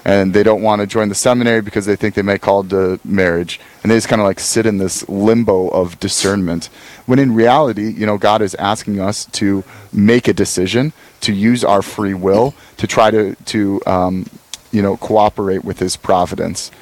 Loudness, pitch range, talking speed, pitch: -15 LUFS, 95-110 Hz, 205 wpm, 105 Hz